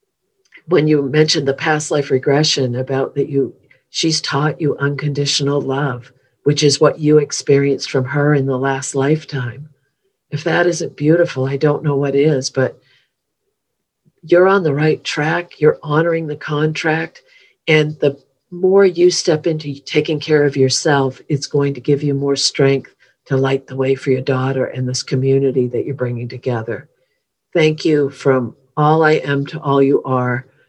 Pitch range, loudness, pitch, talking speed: 135-155 Hz, -16 LUFS, 145 Hz, 170 wpm